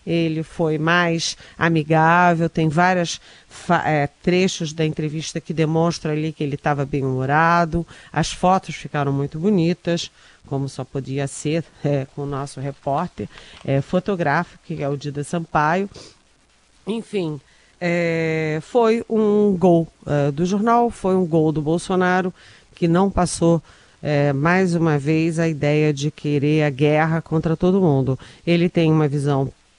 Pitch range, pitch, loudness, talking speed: 145-175 Hz, 160 Hz, -20 LUFS, 135 wpm